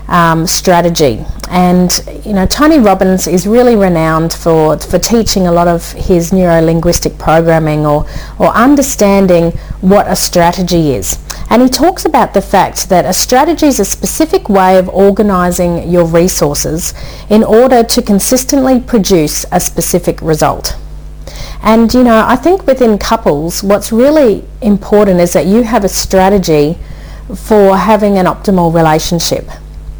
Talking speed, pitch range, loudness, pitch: 145 wpm, 165-220 Hz, -9 LUFS, 185 Hz